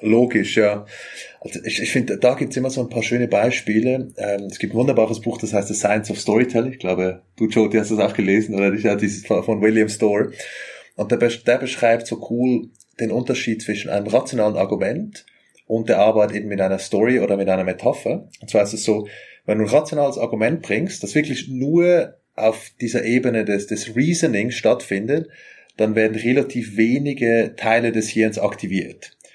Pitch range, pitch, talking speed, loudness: 105-120 Hz, 110 Hz, 185 wpm, -20 LUFS